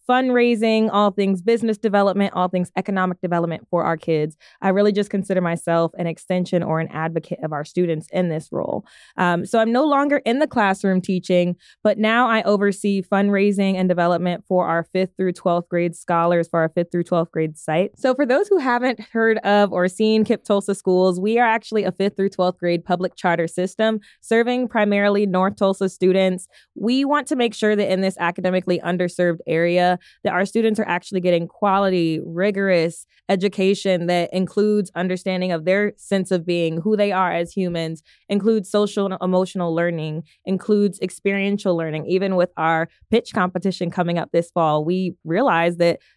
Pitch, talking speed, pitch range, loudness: 185 Hz, 180 wpm, 175-205 Hz, -20 LUFS